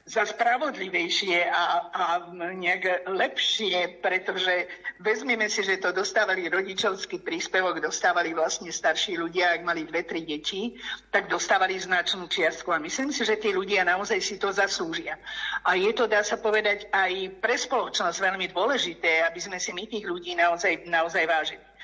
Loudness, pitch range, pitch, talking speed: -26 LUFS, 175-210 Hz, 185 Hz, 155 wpm